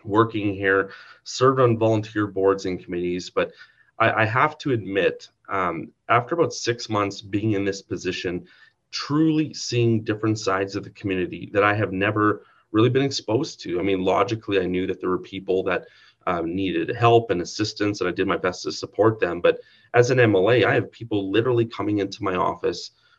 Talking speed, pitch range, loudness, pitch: 190 wpm, 95-120 Hz, -23 LUFS, 105 Hz